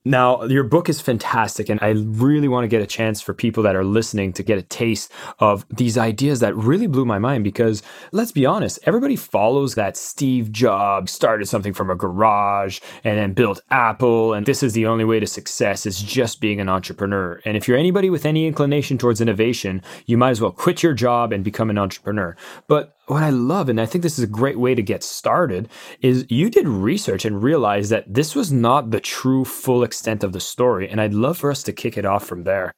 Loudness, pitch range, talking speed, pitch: -19 LUFS, 105-130 Hz, 225 wpm, 115 Hz